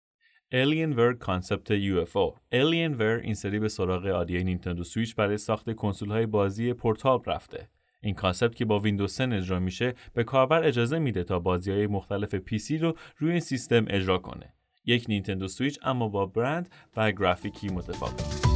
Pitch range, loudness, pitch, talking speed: 100-125 Hz, -28 LUFS, 110 Hz, 170 wpm